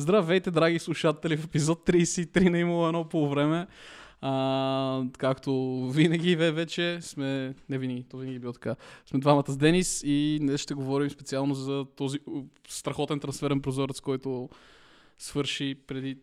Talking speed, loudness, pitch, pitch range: 145 wpm, -28 LUFS, 145 Hz, 135-165 Hz